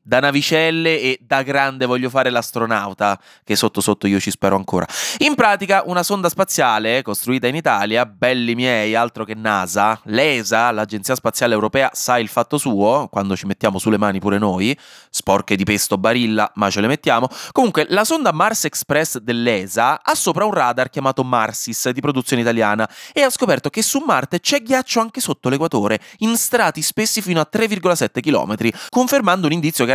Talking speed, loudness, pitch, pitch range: 175 wpm, -17 LUFS, 125 Hz, 110-165 Hz